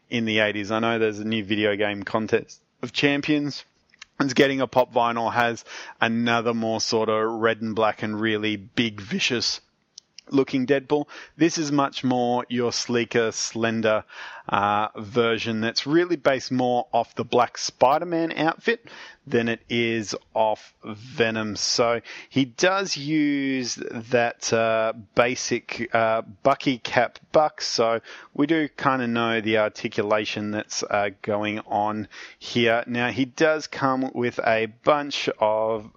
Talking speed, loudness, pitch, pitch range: 145 wpm, -23 LUFS, 115 Hz, 110-135 Hz